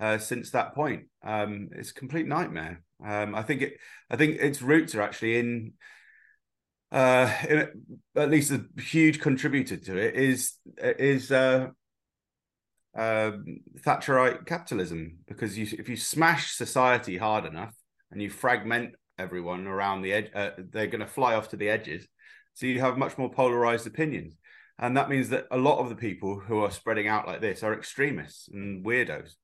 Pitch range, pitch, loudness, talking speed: 105-140 Hz, 120 Hz, -27 LUFS, 175 wpm